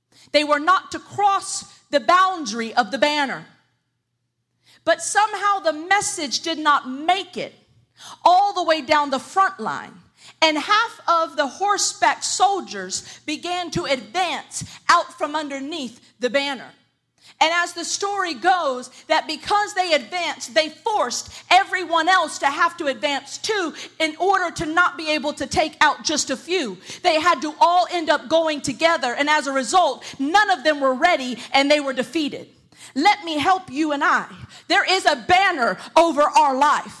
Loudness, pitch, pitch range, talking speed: -20 LUFS, 320 Hz, 280-365 Hz, 165 wpm